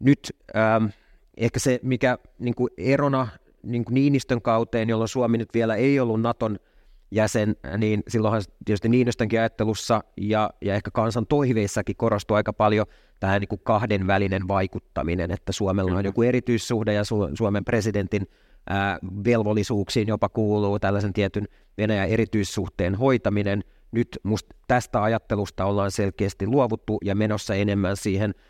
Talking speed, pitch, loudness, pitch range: 140 wpm, 105 Hz, -24 LUFS, 100-115 Hz